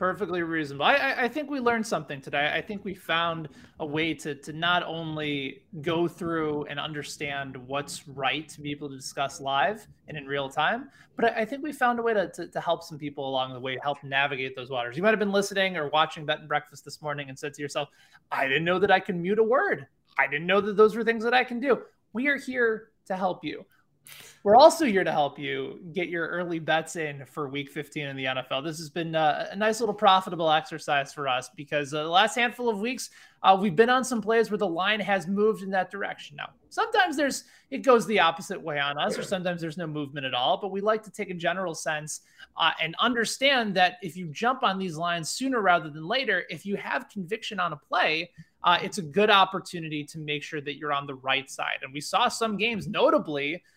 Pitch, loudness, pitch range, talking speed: 170 Hz, -26 LUFS, 150-210 Hz, 240 wpm